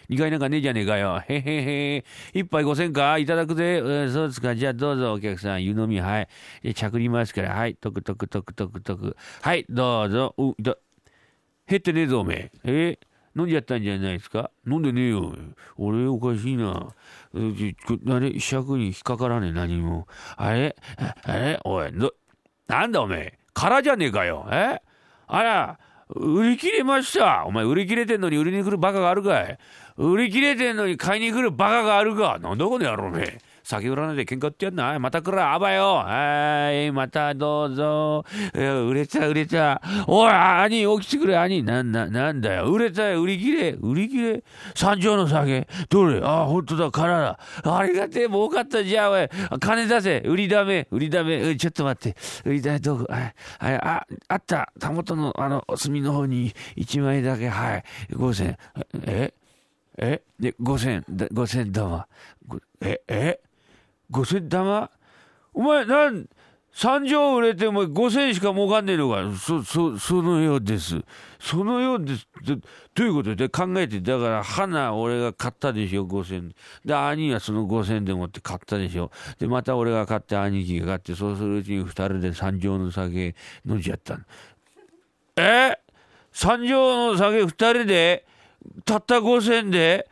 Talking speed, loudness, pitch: 310 characters per minute, -23 LUFS, 145 Hz